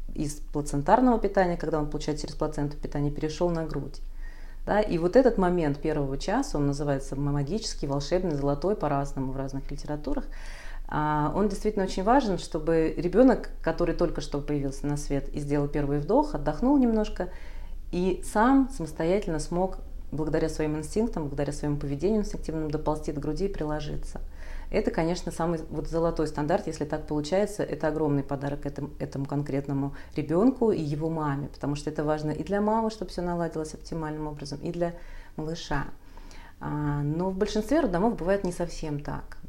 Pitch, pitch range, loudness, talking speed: 155 Hz, 145-180 Hz, -28 LUFS, 160 wpm